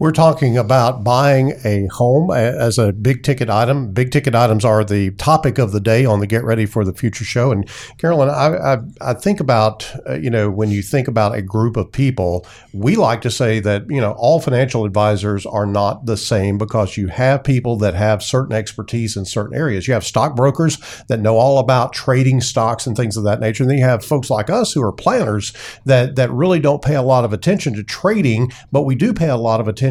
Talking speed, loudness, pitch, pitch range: 230 wpm, -16 LUFS, 120 Hz, 110-135 Hz